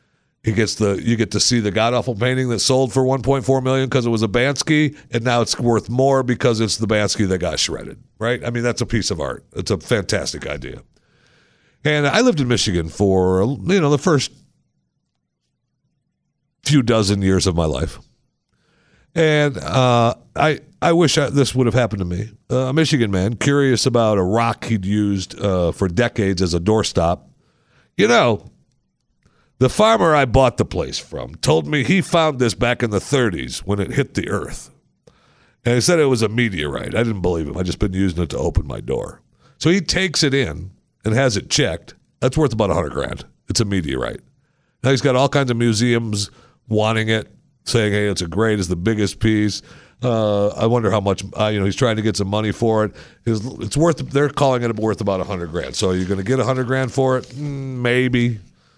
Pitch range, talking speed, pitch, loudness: 105-130 Hz, 210 wpm, 115 Hz, -18 LUFS